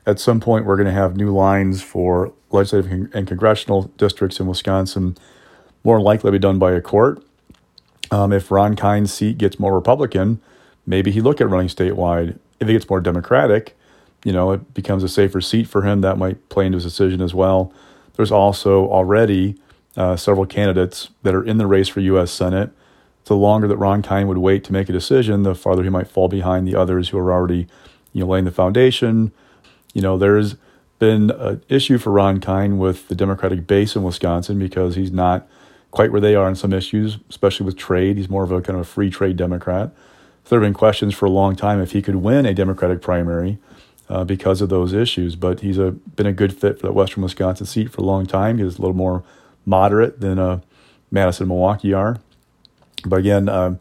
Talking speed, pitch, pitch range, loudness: 215 wpm, 95 Hz, 95-100 Hz, -17 LUFS